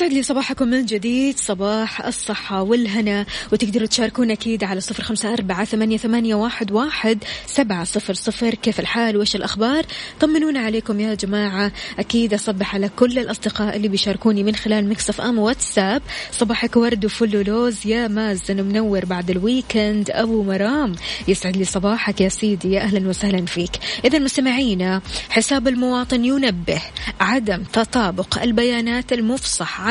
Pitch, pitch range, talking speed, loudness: 220 Hz, 205-235 Hz, 140 wpm, -19 LUFS